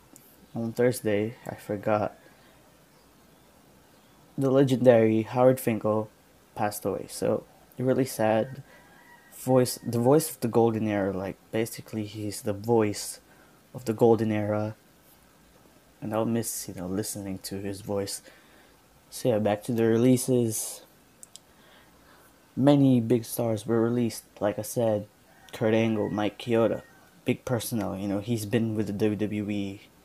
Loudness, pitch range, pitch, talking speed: -27 LUFS, 105-125 Hz, 110 Hz, 130 wpm